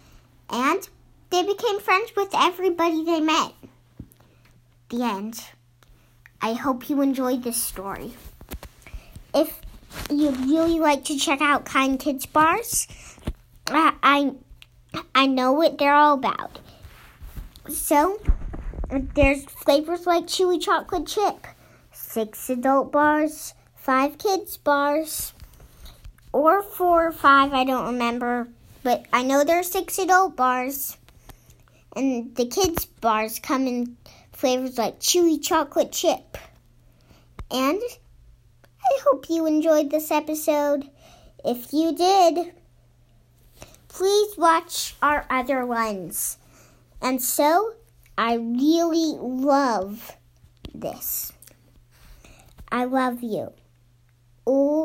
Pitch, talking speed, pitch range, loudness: 280 Hz, 105 wpm, 245-330 Hz, -22 LUFS